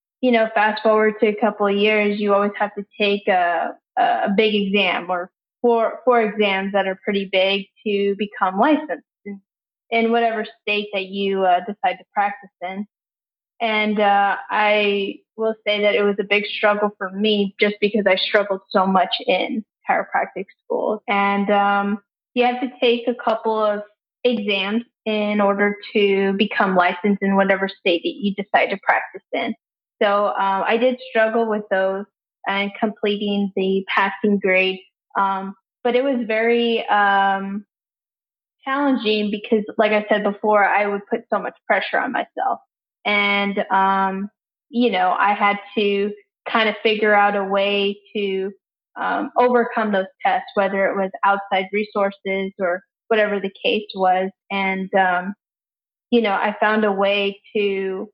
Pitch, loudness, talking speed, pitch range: 205 Hz, -20 LUFS, 160 wpm, 195-220 Hz